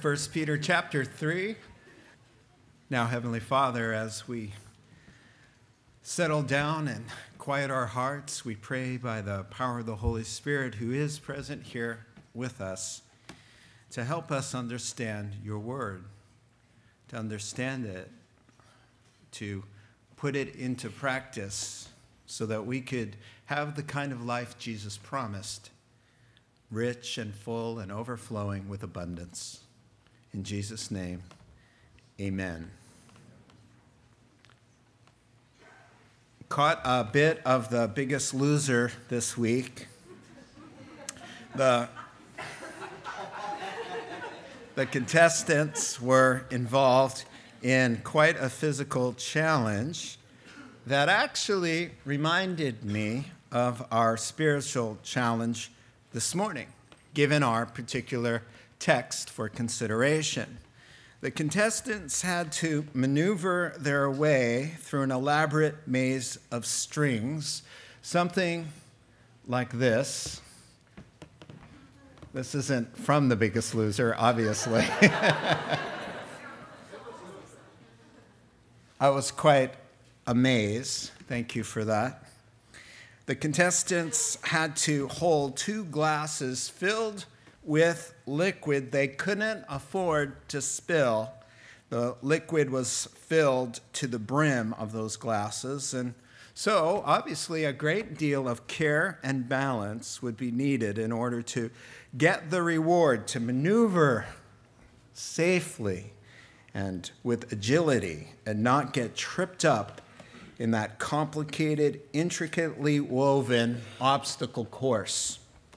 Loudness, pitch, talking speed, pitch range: -29 LUFS, 125 Hz, 100 wpm, 115-145 Hz